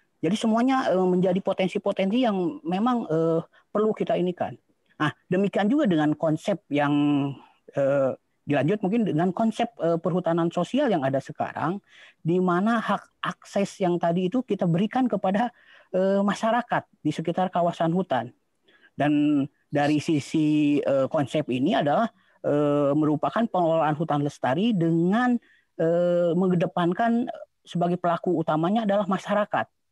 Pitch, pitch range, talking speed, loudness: 180 Hz, 155-205 Hz, 110 wpm, -25 LUFS